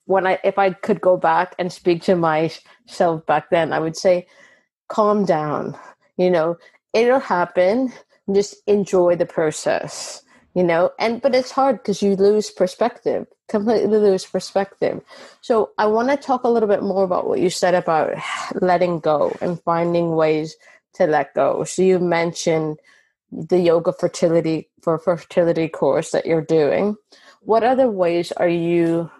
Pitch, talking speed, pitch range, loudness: 185 Hz, 160 wpm, 170-205 Hz, -19 LUFS